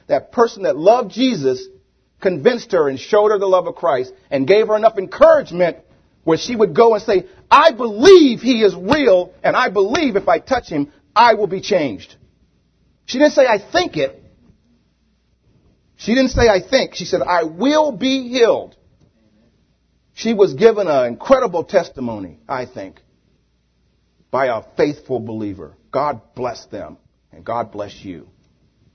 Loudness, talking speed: -16 LUFS, 160 wpm